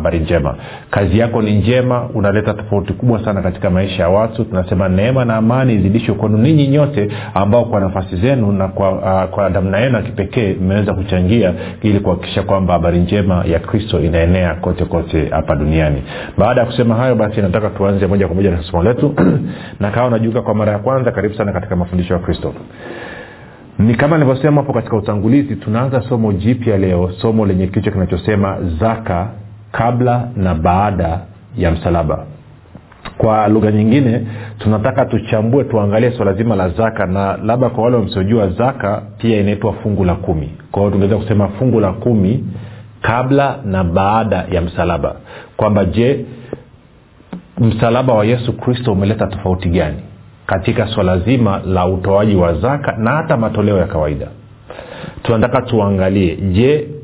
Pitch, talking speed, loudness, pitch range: 105 Hz, 125 wpm, -15 LUFS, 95-115 Hz